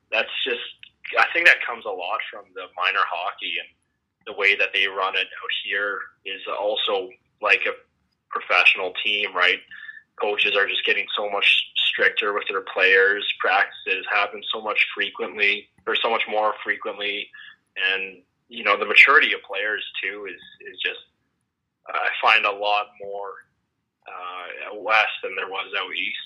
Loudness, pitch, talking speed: -21 LUFS, 125 Hz, 165 wpm